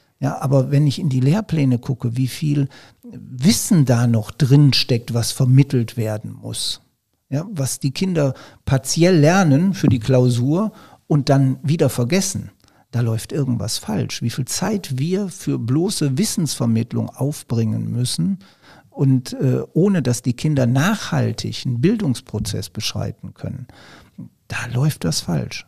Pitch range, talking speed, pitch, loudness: 120-150 Hz, 140 wpm, 135 Hz, -19 LUFS